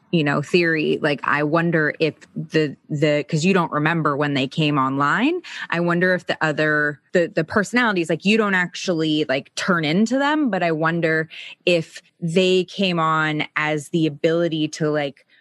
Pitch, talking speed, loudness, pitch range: 160 Hz, 175 wpm, -20 LUFS, 150-180 Hz